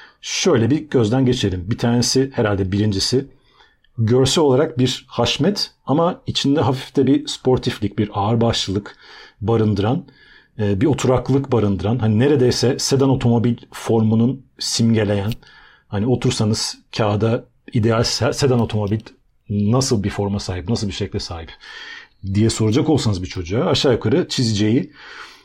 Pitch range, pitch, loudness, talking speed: 105-130 Hz, 115 Hz, -19 LUFS, 125 wpm